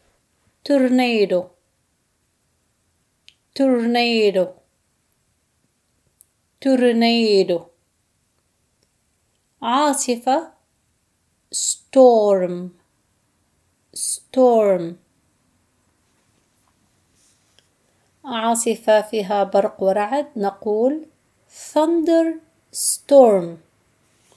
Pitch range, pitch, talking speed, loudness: 195-260 Hz, 225 Hz, 30 wpm, -18 LUFS